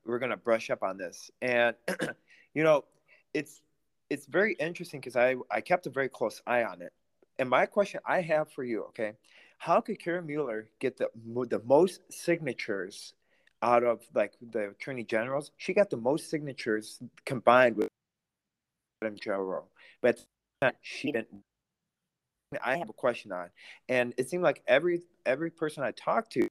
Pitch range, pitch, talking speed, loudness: 120-175 Hz, 145 Hz, 165 wpm, -30 LUFS